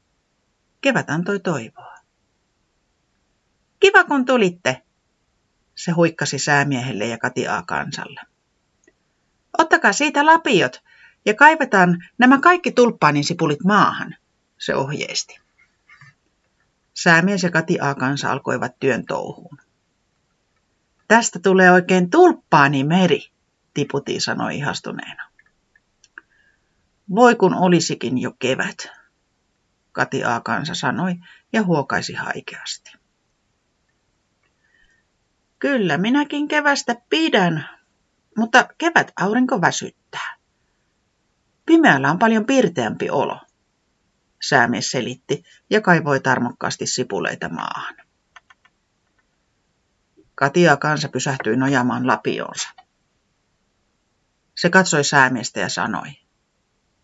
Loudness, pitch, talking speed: -18 LUFS, 185 Hz, 85 wpm